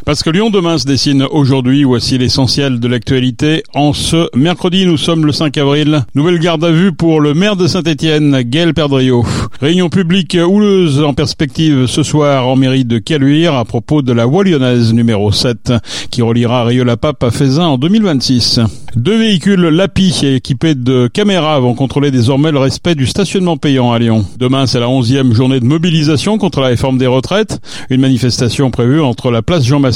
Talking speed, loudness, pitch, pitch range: 185 wpm, -11 LUFS, 140 Hz, 125-165 Hz